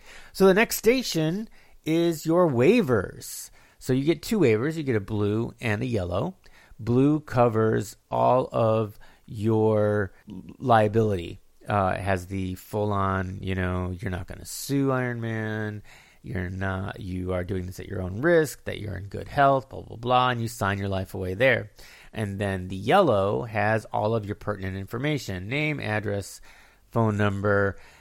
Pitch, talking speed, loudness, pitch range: 105 Hz, 170 wpm, -25 LUFS, 95-125 Hz